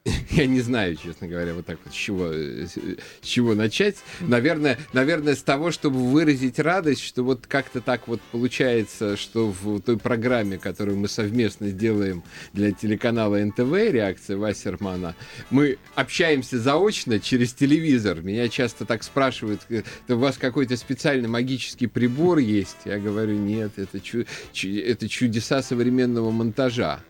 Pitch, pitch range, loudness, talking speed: 120 Hz, 105-130 Hz, -23 LUFS, 140 wpm